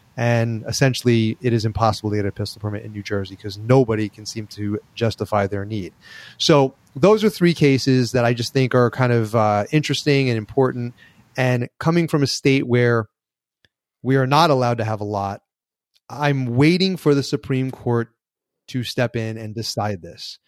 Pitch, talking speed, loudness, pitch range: 120 Hz, 185 wpm, -20 LUFS, 110-135 Hz